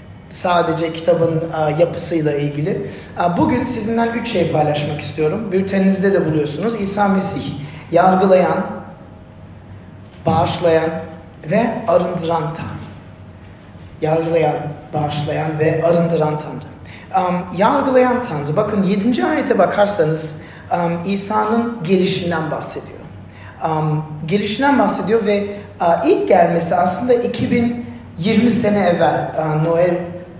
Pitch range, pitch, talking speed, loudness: 155-205 Hz, 170 Hz, 100 wpm, -17 LUFS